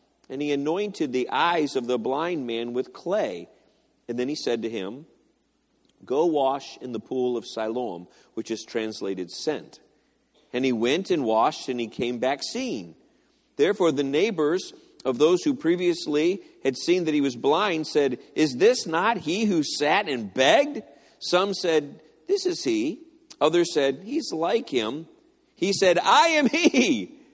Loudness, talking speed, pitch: -24 LUFS, 165 wpm, 160 Hz